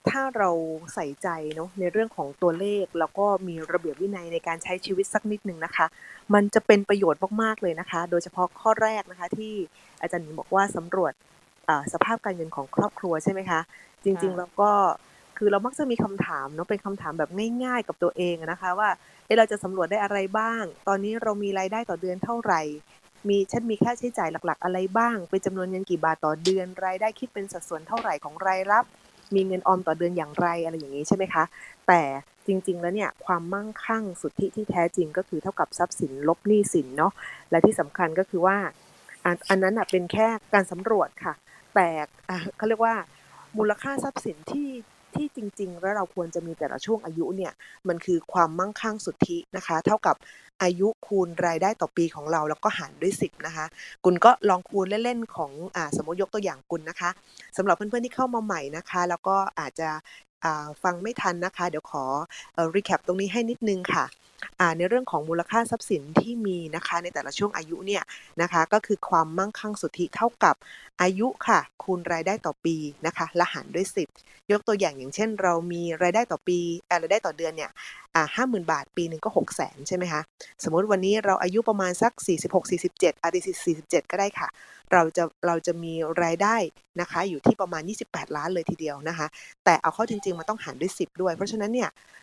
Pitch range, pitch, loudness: 170-205 Hz, 185 Hz, -26 LUFS